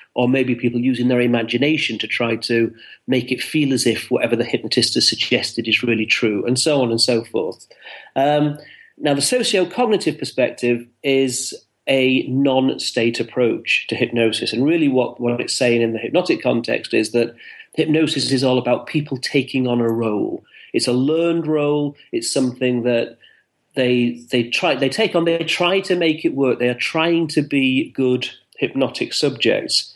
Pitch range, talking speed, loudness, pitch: 120-150 Hz, 175 wpm, -18 LUFS, 130 Hz